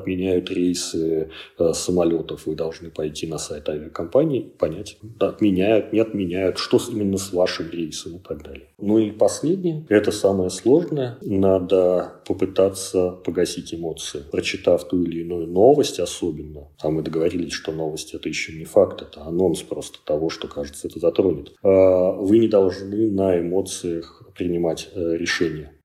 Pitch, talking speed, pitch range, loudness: 90 Hz, 150 wpm, 85-100 Hz, -22 LUFS